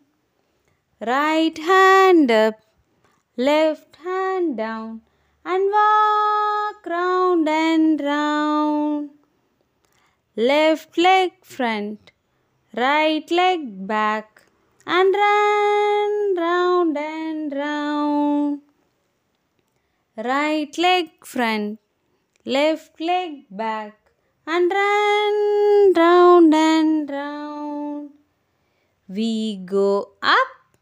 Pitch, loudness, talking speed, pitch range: 310 Hz, -19 LUFS, 70 wpm, 285-365 Hz